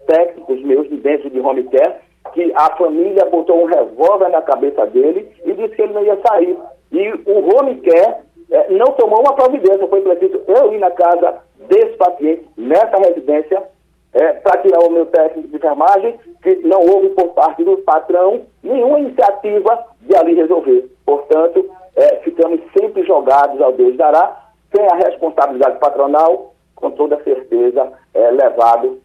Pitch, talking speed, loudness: 200 Hz, 165 wpm, -13 LUFS